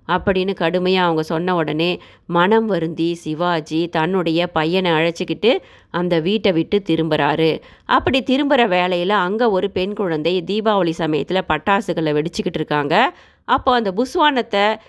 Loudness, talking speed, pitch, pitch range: -18 LUFS, 120 wpm, 180 Hz, 165-205 Hz